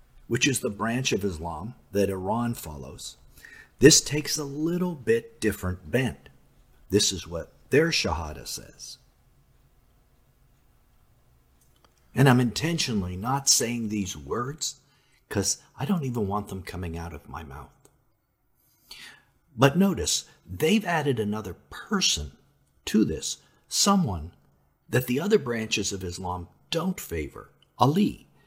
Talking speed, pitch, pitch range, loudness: 120 wpm, 115 Hz, 90-145 Hz, -26 LUFS